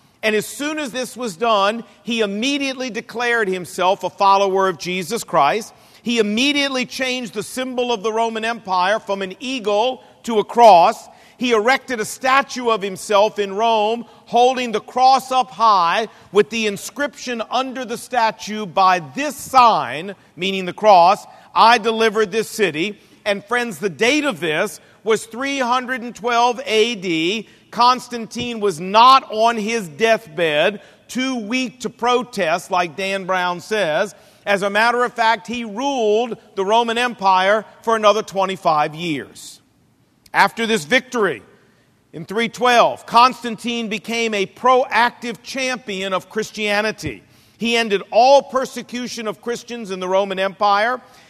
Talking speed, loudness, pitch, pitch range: 140 wpm, -18 LUFS, 225 Hz, 200-245 Hz